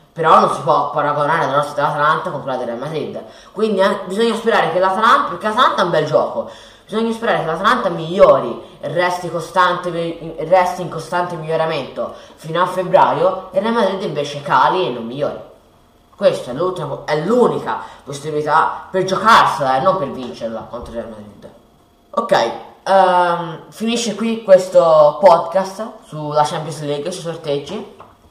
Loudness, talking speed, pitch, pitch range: -16 LUFS, 155 wpm, 175 Hz, 150-195 Hz